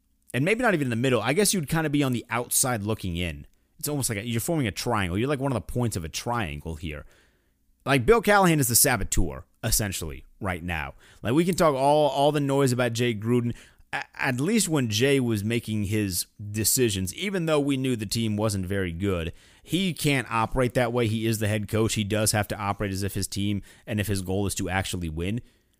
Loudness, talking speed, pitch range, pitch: -25 LUFS, 235 wpm, 95-135 Hz, 110 Hz